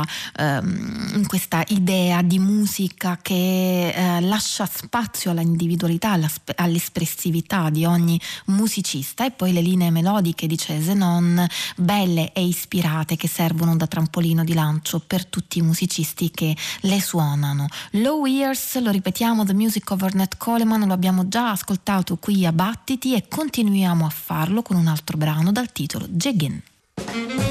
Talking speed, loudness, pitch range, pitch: 140 wpm, -21 LUFS, 165-205 Hz, 180 Hz